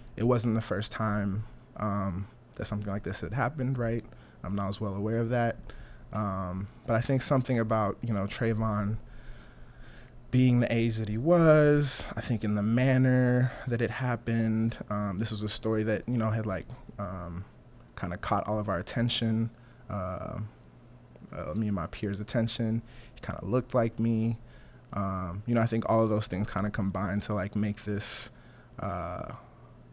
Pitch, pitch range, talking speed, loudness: 110 Hz, 100-120 Hz, 180 wpm, -30 LUFS